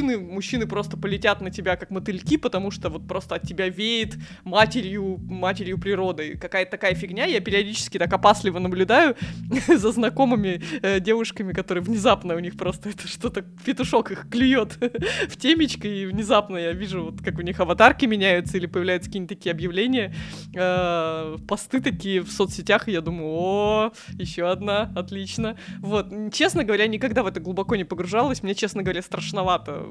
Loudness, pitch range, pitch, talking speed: -23 LUFS, 180-215 Hz, 195 Hz, 160 wpm